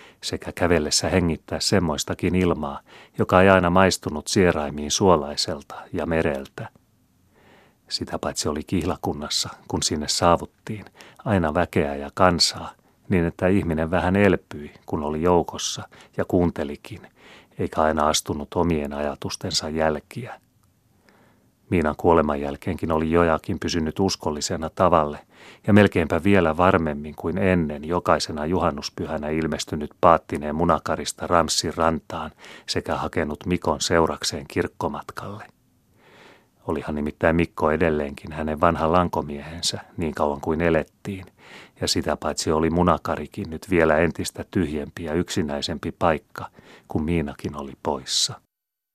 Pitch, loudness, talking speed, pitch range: 80 Hz, -23 LUFS, 115 wpm, 75-90 Hz